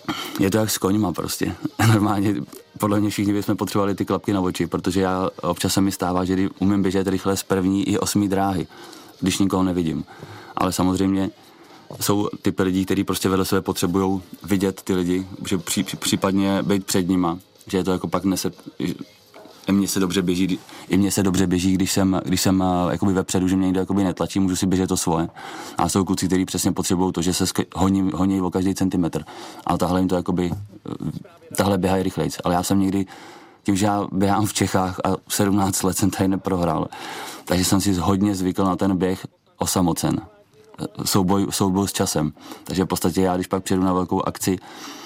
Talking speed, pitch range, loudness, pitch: 195 wpm, 95-100 Hz, -22 LUFS, 95 Hz